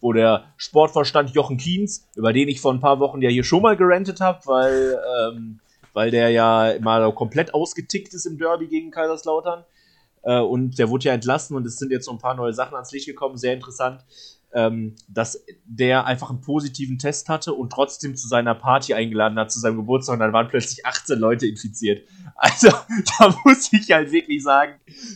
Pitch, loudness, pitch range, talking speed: 130 Hz, -20 LUFS, 120-160 Hz, 200 wpm